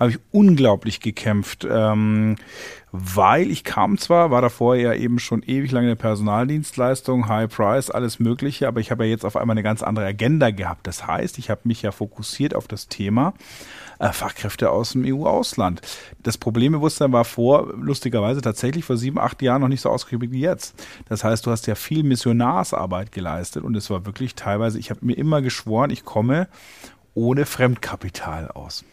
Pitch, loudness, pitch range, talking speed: 115 Hz, -21 LUFS, 105-130 Hz, 180 wpm